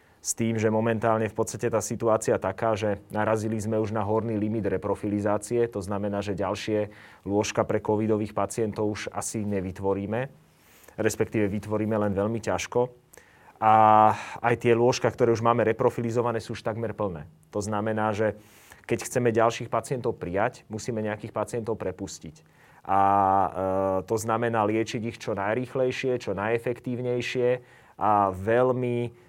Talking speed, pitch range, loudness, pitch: 140 wpm, 105-115 Hz, -26 LUFS, 110 Hz